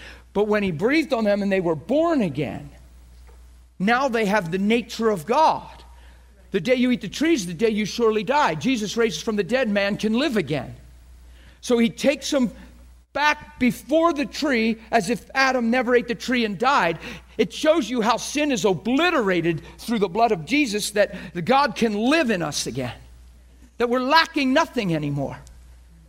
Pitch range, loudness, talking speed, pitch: 165-255 Hz, -22 LUFS, 185 wpm, 220 Hz